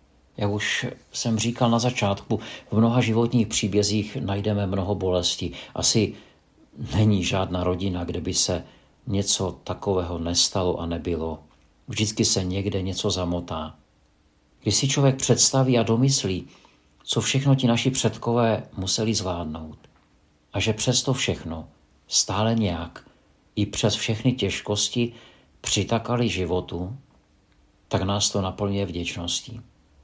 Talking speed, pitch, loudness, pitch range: 120 wpm, 100 Hz, -24 LUFS, 85-115 Hz